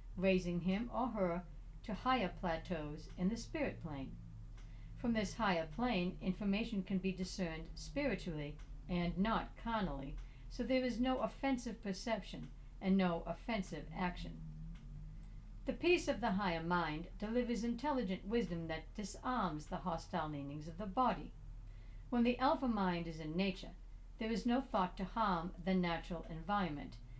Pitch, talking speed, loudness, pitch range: 185 Hz, 145 wpm, -39 LUFS, 165-225 Hz